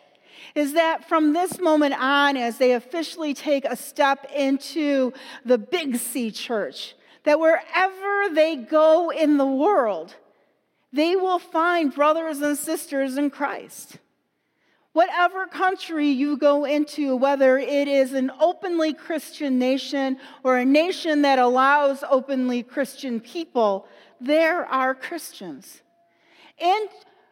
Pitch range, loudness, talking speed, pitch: 270-325 Hz, -22 LUFS, 125 wpm, 295 Hz